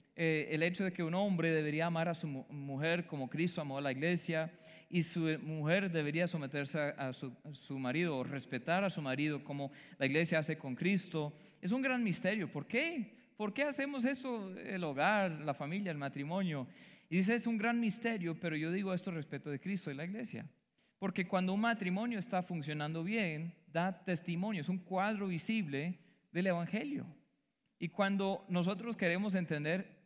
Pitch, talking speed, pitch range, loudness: 175 Hz, 185 wpm, 155-195 Hz, -37 LUFS